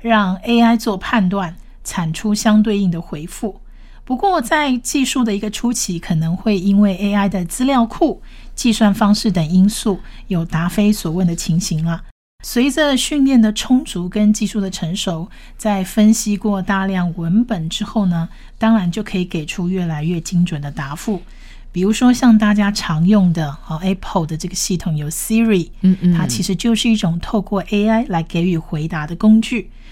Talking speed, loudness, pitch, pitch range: 275 characters per minute, -17 LUFS, 200 Hz, 175-220 Hz